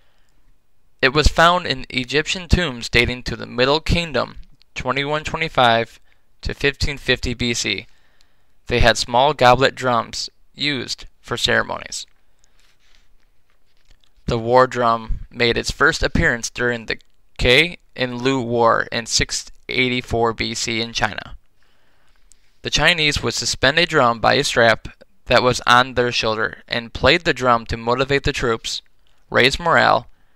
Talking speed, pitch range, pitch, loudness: 130 wpm, 115-130 Hz, 120 Hz, -18 LUFS